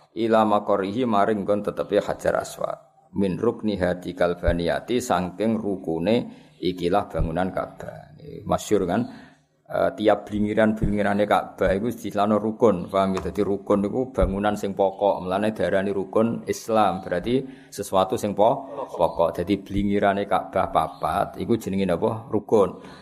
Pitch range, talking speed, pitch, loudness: 95-105 Hz, 130 wpm, 100 Hz, -24 LUFS